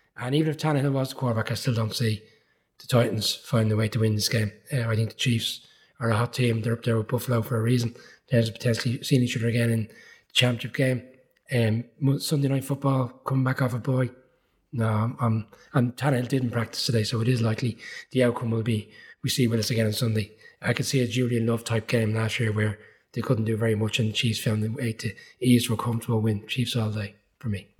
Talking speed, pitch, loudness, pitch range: 245 wpm, 120 Hz, -26 LUFS, 110-130 Hz